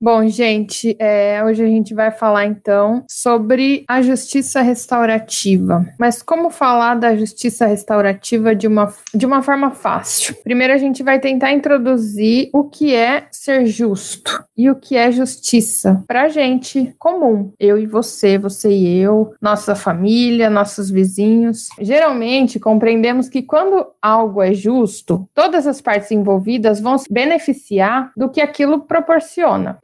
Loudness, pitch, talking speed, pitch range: -15 LUFS, 230 Hz, 145 wpm, 210-265 Hz